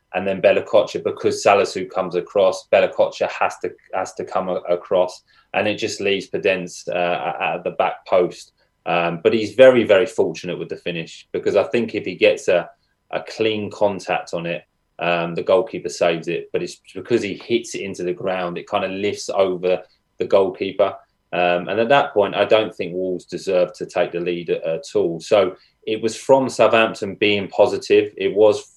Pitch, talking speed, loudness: 110 Hz, 190 wpm, -20 LUFS